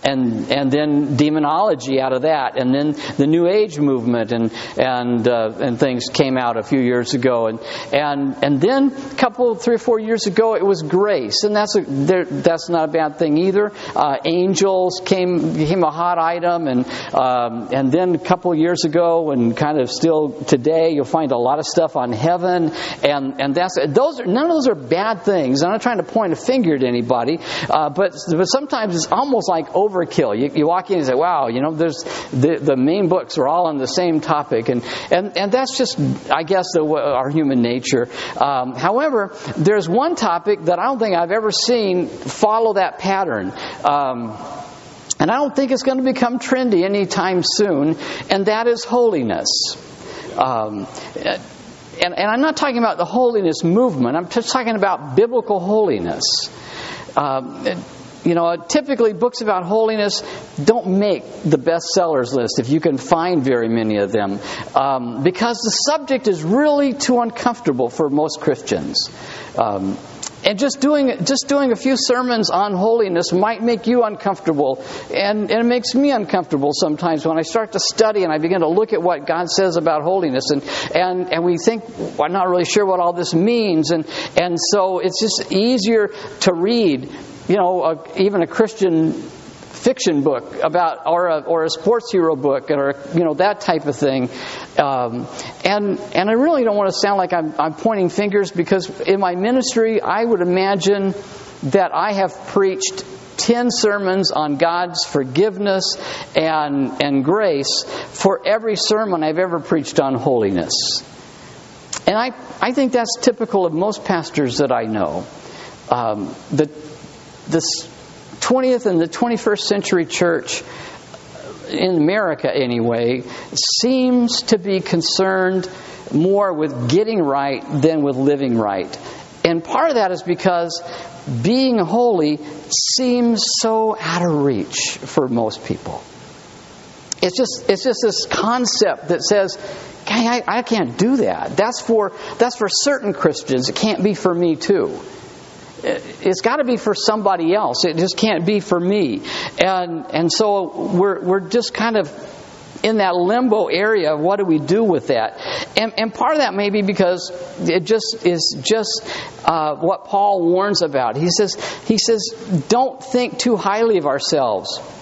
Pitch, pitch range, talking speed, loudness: 185 Hz, 160-220 Hz, 175 wpm, -18 LUFS